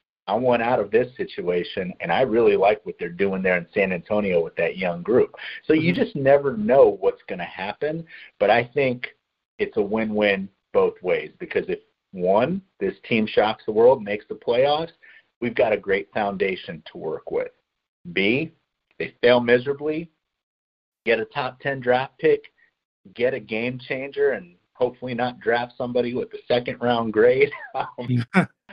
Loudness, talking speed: -23 LUFS, 170 wpm